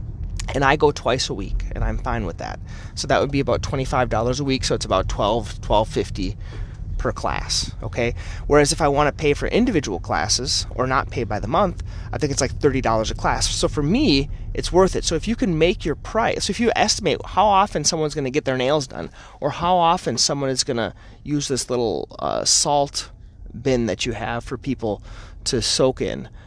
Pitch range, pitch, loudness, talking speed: 105-145 Hz, 125 Hz, -21 LUFS, 220 wpm